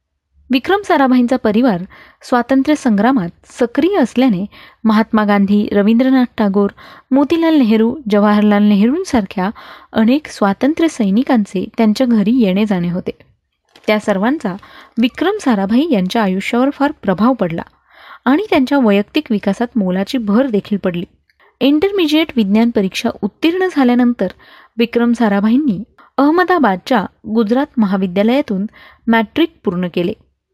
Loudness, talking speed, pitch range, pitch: -14 LUFS, 100 wpm, 205-265 Hz, 230 Hz